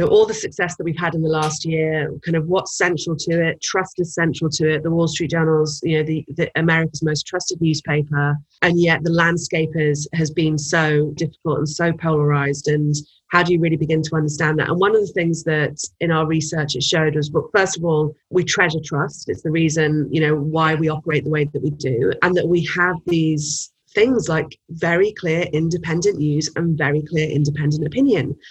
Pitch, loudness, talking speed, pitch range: 160 Hz, -19 LUFS, 220 wpm, 150-170 Hz